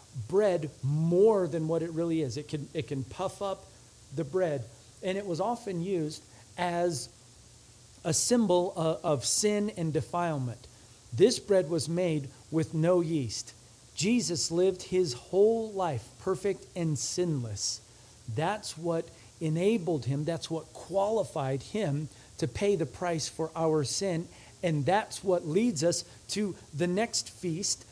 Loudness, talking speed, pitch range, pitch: -30 LUFS, 145 wpm, 140-185 Hz, 165 Hz